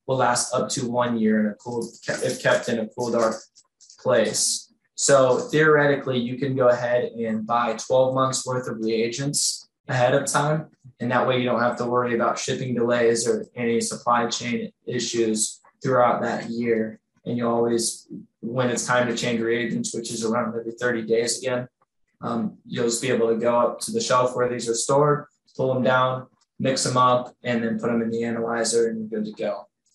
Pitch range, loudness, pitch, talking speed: 115-130 Hz, -23 LUFS, 120 Hz, 200 wpm